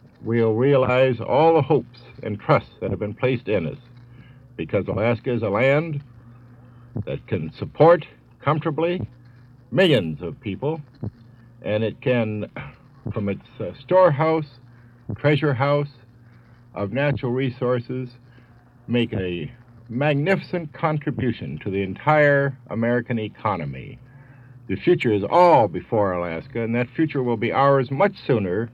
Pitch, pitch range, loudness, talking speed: 125 Hz, 115-140 Hz, -22 LUFS, 125 wpm